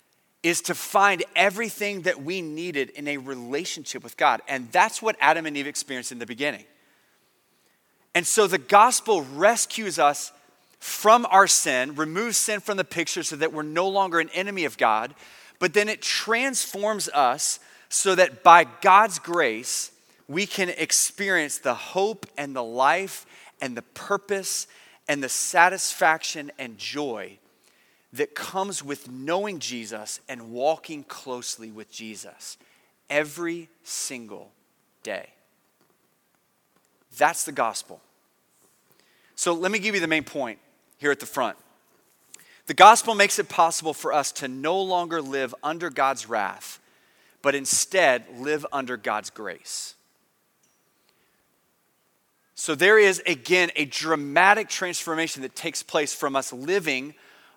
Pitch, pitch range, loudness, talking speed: 160 Hz, 140-195 Hz, -23 LUFS, 140 wpm